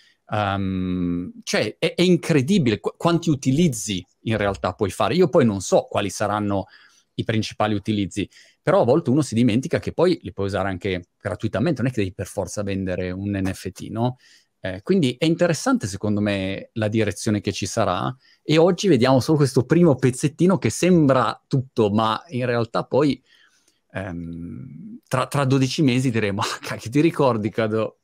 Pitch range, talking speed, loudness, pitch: 100-140 Hz, 170 wpm, -21 LUFS, 110 Hz